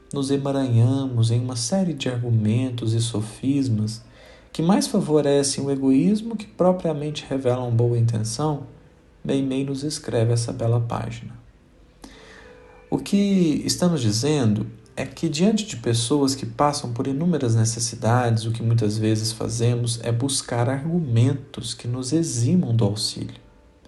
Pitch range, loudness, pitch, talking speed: 115-150 Hz, -22 LUFS, 125 Hz, 130 wpm